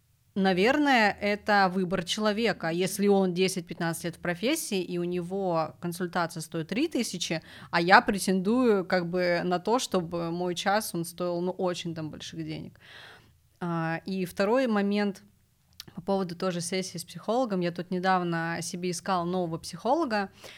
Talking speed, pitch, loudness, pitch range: 145 wpm, 180 Hz, -28 LUFS, 170-200 Hz